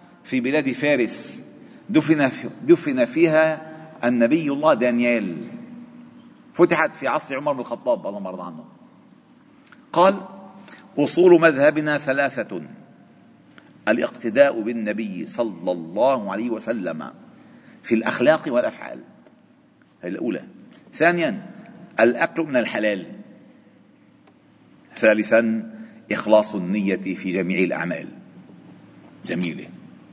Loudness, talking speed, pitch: -21 LUFS, 85 wpm, 165 Hz